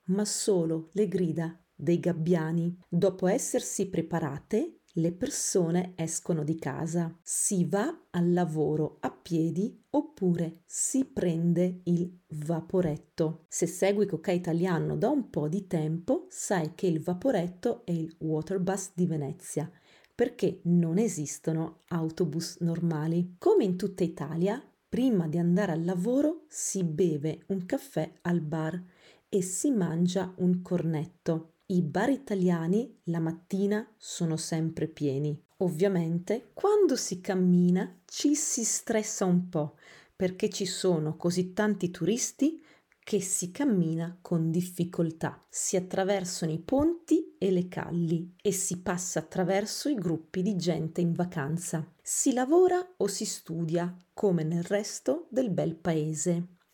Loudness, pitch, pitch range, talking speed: -29 LUFS, 180 Hz, 165-205 Hz, 130 wpm